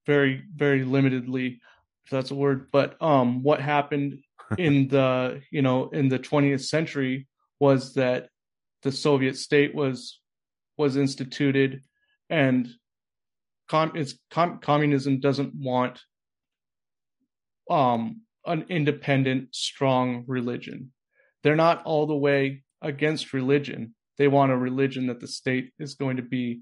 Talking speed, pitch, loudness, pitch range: 130 wpm, 140 Hz, -25 LUFS, 130-145 Hz